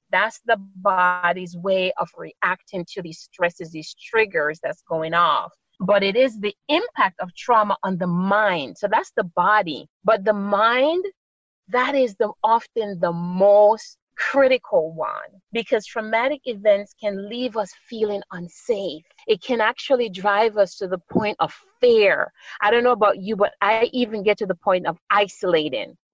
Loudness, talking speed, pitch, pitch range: -21 LUFS, 165 wpm, 210 Hz, 190-245 Hz